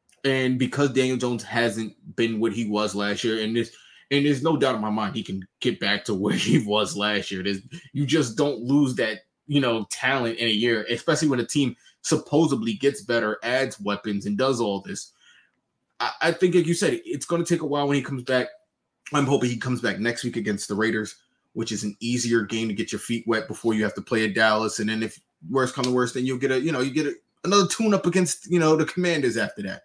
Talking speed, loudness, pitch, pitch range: 250 wpm, -24 LUFS, 125 Hz, 110-145 Hz